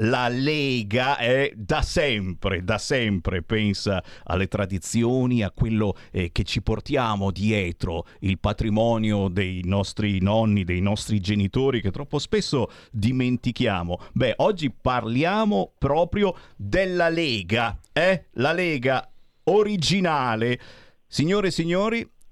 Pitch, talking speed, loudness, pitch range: 110 Hz, 115 wpm, -24 LUFS, 100-130 Hz